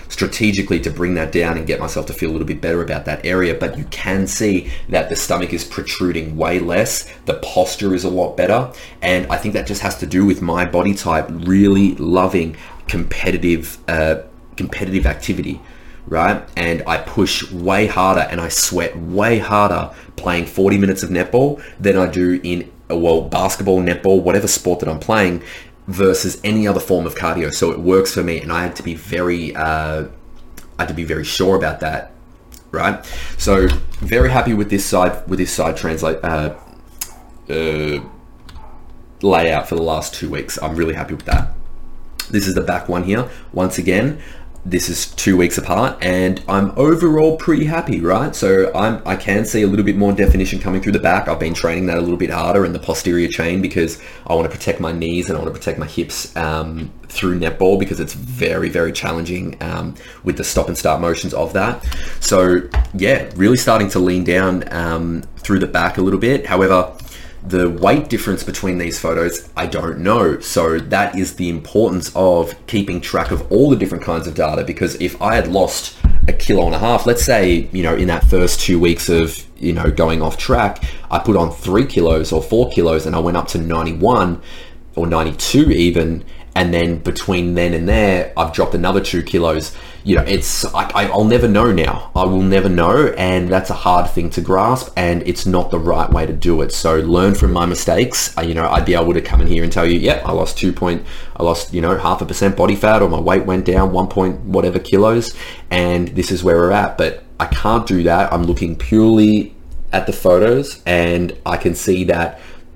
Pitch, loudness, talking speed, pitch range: 90 Hz, -16 LUFS, 210 wpm, 80-95 Hz